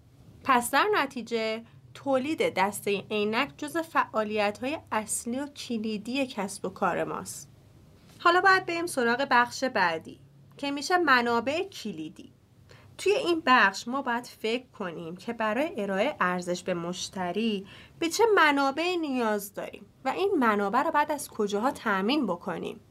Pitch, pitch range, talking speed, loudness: 235 Hz, 205-295 Hz, 140 wpm, -27 LUFS